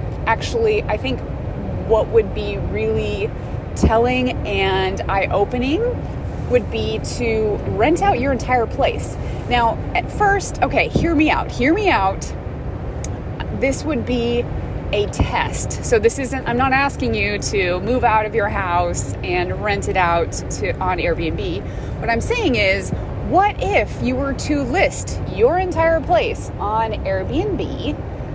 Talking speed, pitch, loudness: 145 wpm, 330 Hz, -19 LUFS